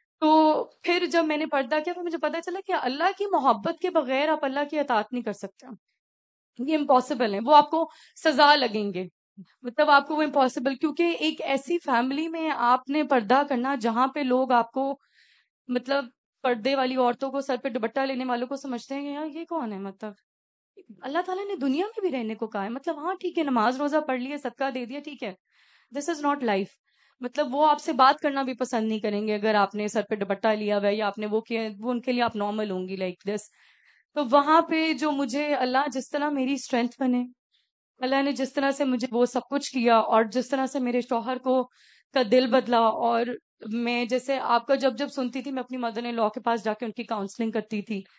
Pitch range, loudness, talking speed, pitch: 235-295 Hz, -26 LUFS, 230 wpm, 260 Hz